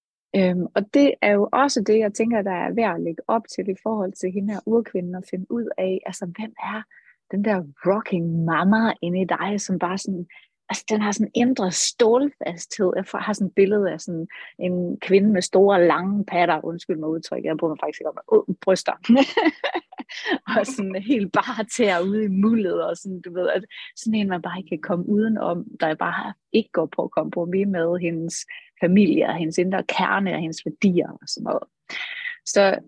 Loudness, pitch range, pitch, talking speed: -22 LUFS, 180-220 Hz, 195 Hz, 210 wpm